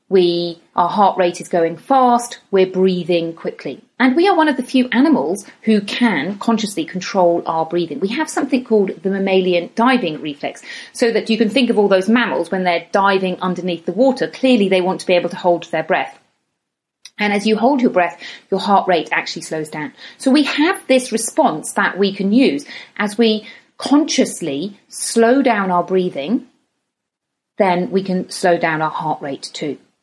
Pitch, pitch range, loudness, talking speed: 200 Hz, 180-245 Hz, -17 LUFS, 190 wpm